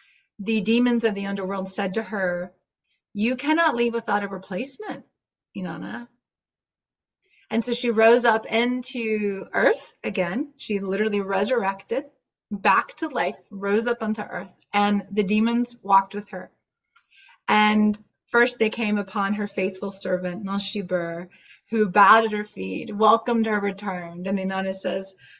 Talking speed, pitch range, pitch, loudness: 140 wpm, 195-230 Hz, 210 Hz, -23 LUFS